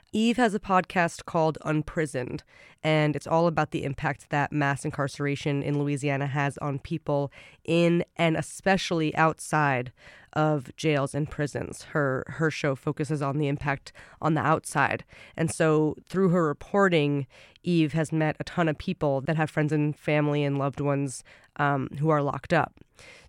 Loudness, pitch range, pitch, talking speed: -27 LUFS, 140-160 Hz, 150 Hz, 160 wpm